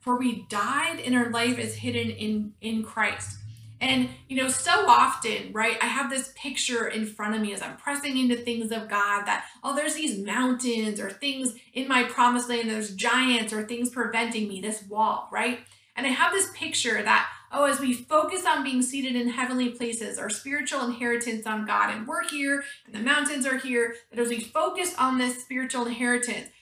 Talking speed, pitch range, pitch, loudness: 205 wpm, 220-265 Hz, 245 Hz, -26 LUFS